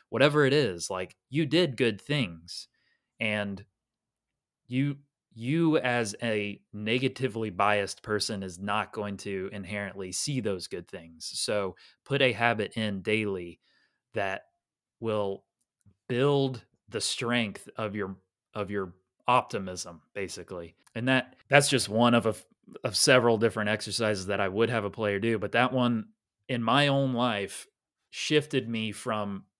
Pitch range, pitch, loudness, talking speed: 100-130 Hz, 110 Hz, -28 LUFS, 140 wpm